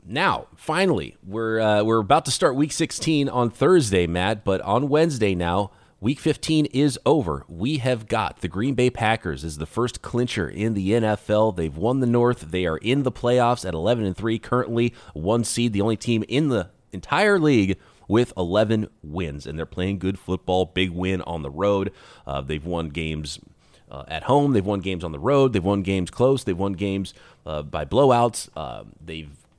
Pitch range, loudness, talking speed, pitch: 90-120 Hz, -23 LUFS, 195 wpm, 105 Hz